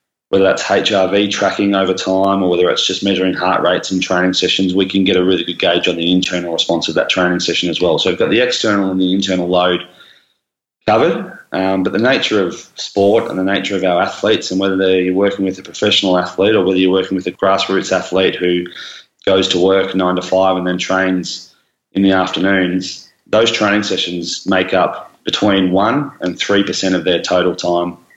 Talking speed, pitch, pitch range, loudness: 205 wpm, 95 Hz, 90-95 Hz, -14 LUFS